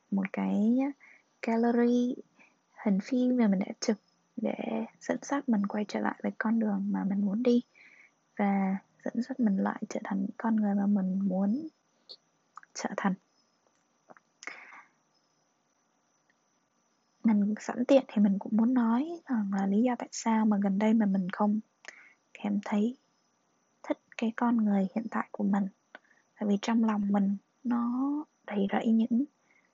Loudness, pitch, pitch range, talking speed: -30 LUFS, 220 Hz, 200-240 Hz, 155 wpm